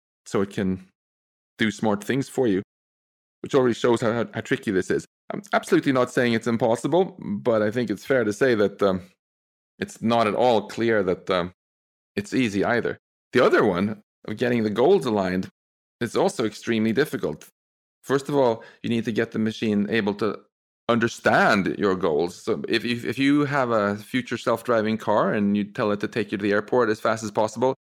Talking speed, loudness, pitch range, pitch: 195 wpm, -23 LUFS, 95-120 Hz, 110 Hz